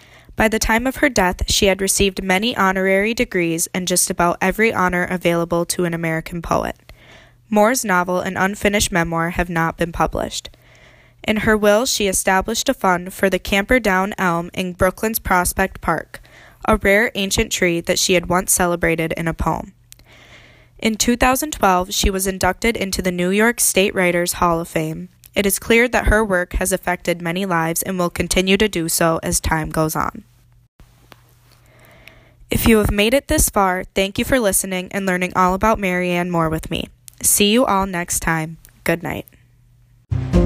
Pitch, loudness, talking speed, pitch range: 180 Hz, -18 LUFS, 175 wpm, 165-200 Hz